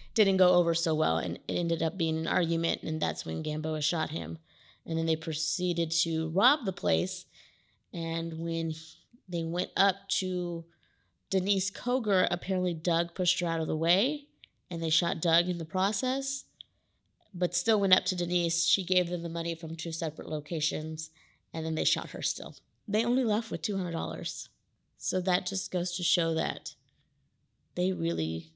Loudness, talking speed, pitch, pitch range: -30 LUFS, 175 wpm, 170 Hz, 160-185 Hz